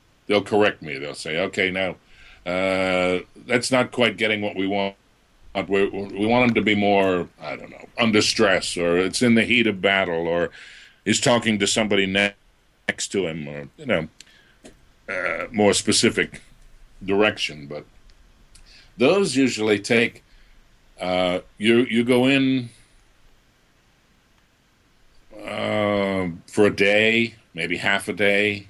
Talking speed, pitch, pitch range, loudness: 135 wpm, 105 Hz, 95-115 Hz, -21 LUFS